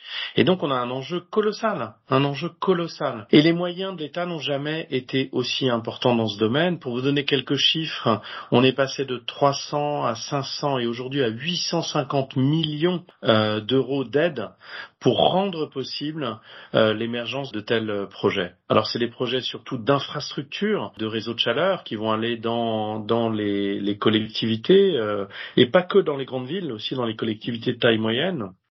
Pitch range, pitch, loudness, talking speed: 115-155 Hz, 135 Hz, -23 LUFS, 170 wpm